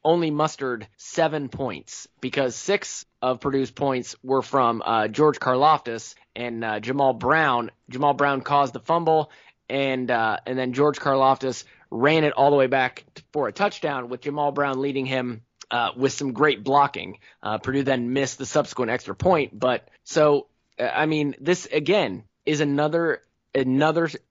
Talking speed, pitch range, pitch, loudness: 160 wpm, 125-150 Hz, 135 Hz, -23 LUFS